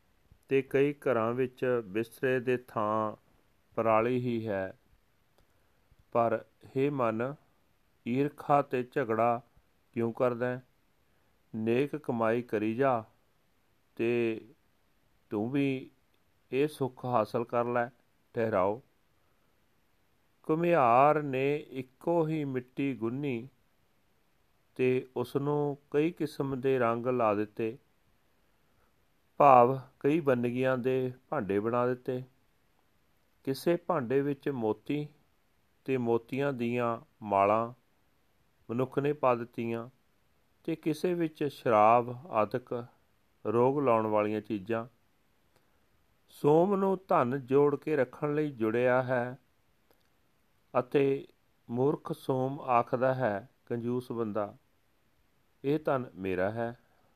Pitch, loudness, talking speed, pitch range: 125 Hz, -30 LUFS, 100 wpm, 115-140 Hz